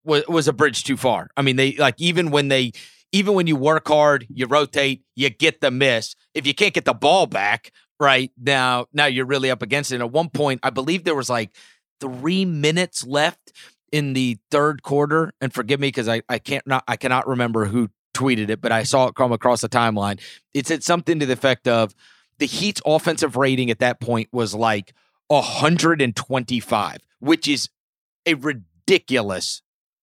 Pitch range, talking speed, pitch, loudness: 125-150 Hz, 190 wpm, 135 Hz, -20 LUFS